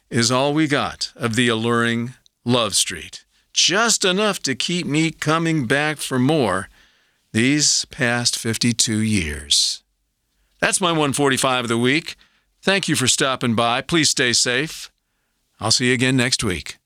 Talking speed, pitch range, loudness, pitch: 150 wpm, 115-150 Hz, -18 LUFS, 130 Hz